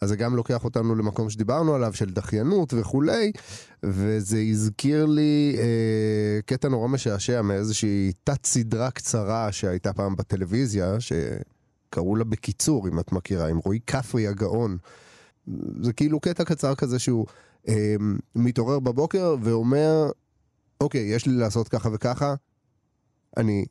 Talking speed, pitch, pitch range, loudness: 130 wpm, 115 Hz, 105-135 Hz, -25 LUFS